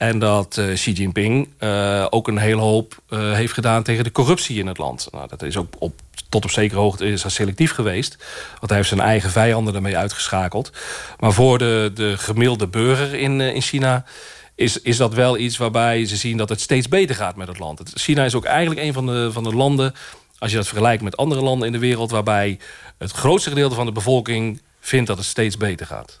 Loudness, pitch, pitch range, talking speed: -19 LUFS, 115 Hz, 105-125 Hz, 225 wpm